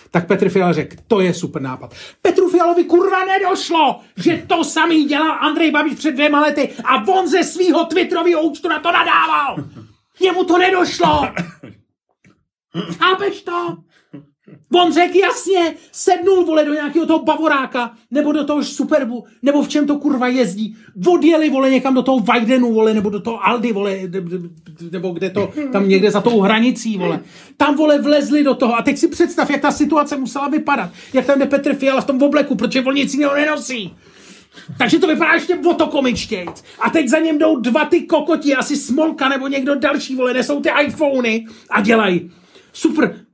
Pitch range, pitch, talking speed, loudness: 235-320 Hz, 285 Hz, 180 wpm, -16 LUFS